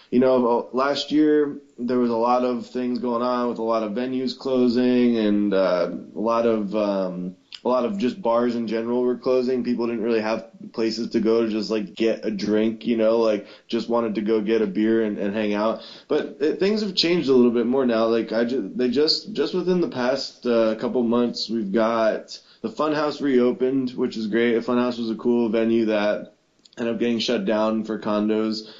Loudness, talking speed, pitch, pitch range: -22 LUFS, 215 wpm, 115 Hz, 110-125 Hz